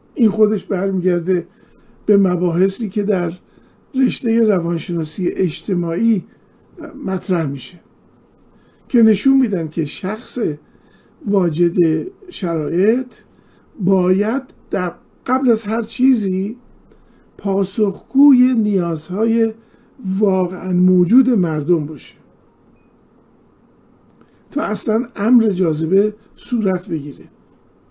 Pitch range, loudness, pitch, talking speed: 180-230 Hz, -17 LUFS, 200 Hz, 80 wpm